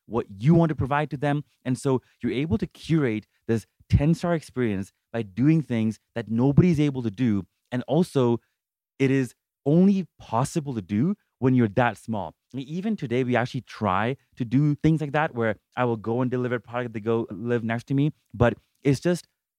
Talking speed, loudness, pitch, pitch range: 190 wpm, -25 LUFS, 125 Hz, 115-145 Hz